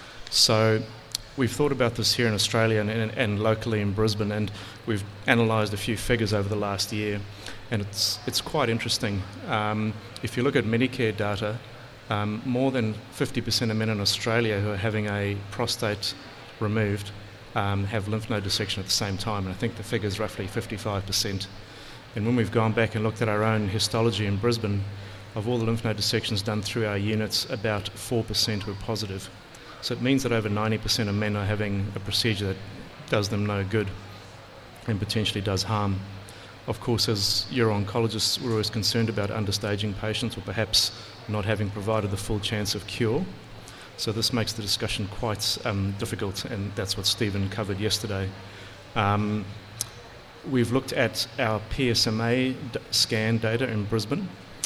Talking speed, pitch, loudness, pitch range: 175 wpm, 110 Hz, -26 LUFS, 105-115 Hz